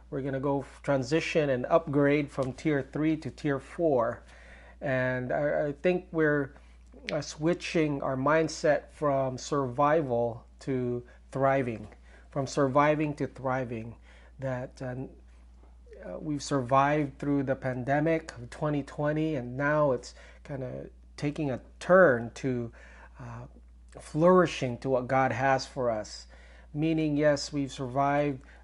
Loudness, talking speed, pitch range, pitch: -29 LUFS, 115 wpm, 120-150 Hz, 135 Hz